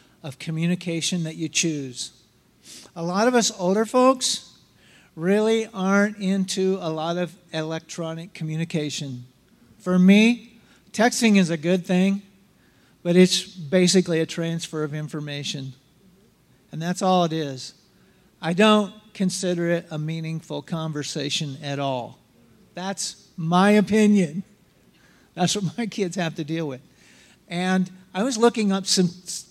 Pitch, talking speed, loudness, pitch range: 180 Hz, 130 wpm, -23 LUFS, 160-195 Hz